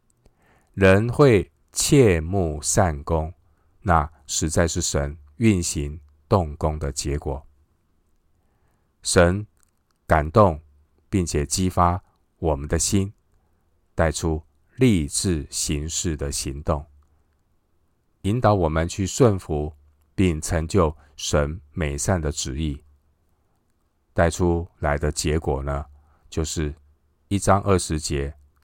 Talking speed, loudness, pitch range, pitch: 140 characters per minute, -22 LUFS, 75-90 Hz, 80 Hz